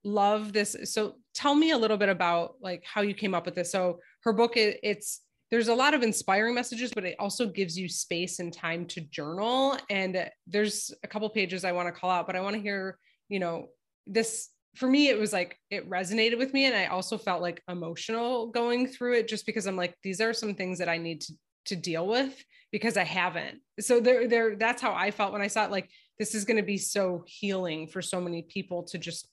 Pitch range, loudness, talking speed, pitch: 180-225 Hz, -29 LUFS, 235 wpm, 200 Hz